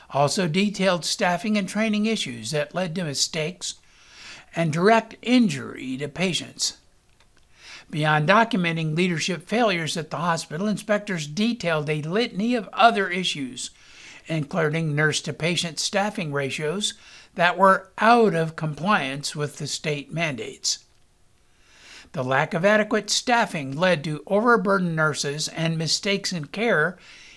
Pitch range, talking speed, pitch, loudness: 155-205 Hz, 125 wpm, 175 Hz, -23 LUFS